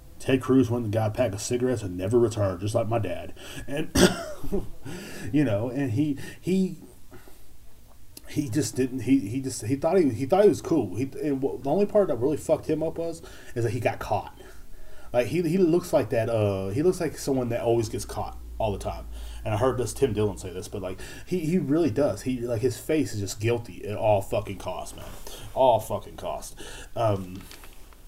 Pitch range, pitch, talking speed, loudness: 100-140 Hz, 120 Hz, 210 wpm, -26 LUFS